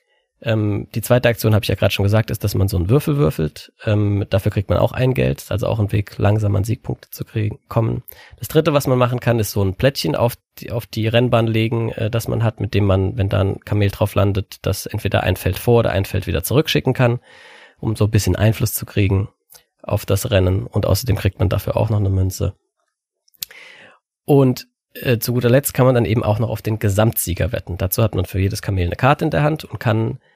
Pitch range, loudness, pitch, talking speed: 100-120 Hz, -19 LUFS, 110 Hz, 235 wpm